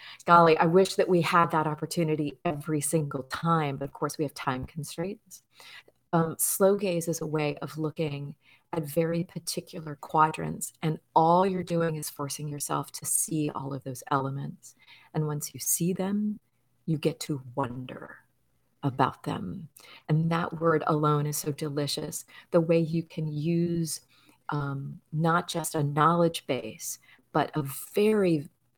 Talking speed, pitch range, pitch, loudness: 155 wpm, 145-170 Hz, 155 Hz, -28 LUFS